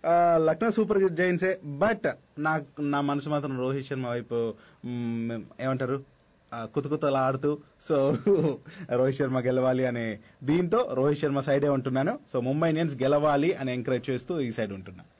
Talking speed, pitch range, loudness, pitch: 130 wpm, 130-155 Hz, -27 LUFS, 140 Hz